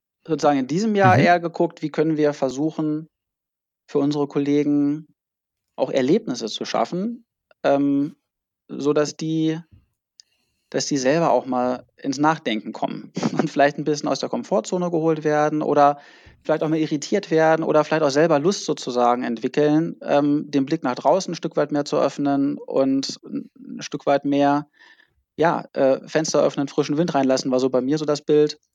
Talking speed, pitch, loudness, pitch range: 165 wpm, 150 Hz, -21 LUFS, 145-160 Hz